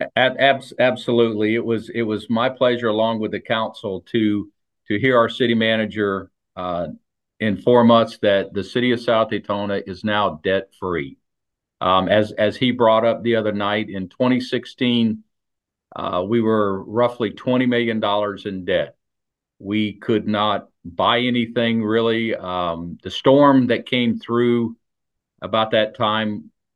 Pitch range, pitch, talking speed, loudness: 105-120 Hz, 110 Hz, 145 wpm, -20 LUFS